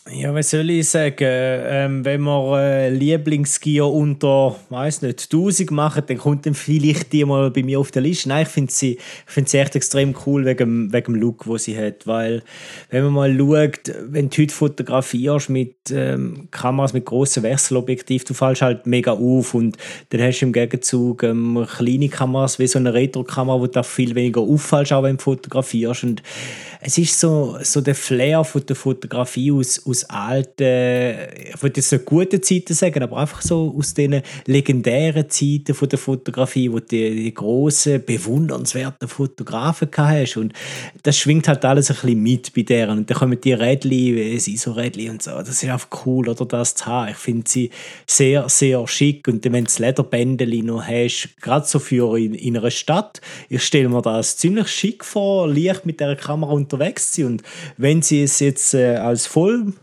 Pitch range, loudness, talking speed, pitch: 125-145 Hz, -18 LUFS, 190 wpm, 135 Hz